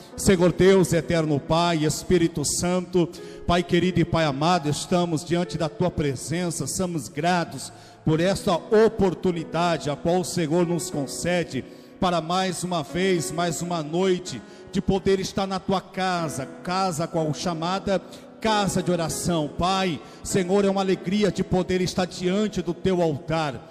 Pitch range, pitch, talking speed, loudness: 160-185 Hz, 175 Hz, 145 wpm, -24 LUFS